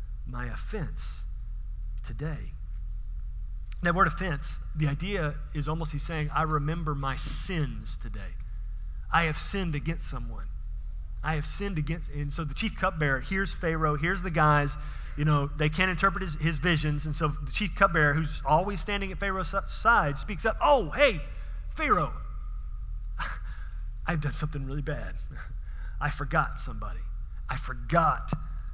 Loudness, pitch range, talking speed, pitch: -29 LUFS, 110-165 Hz, 145 wpm, 150 Hz